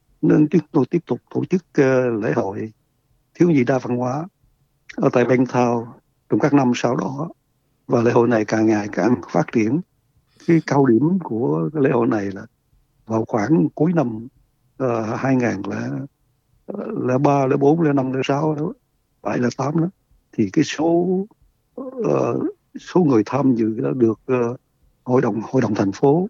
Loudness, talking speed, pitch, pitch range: -20 LUFS, 160 wpm, 130 Hz, 120-150 Hz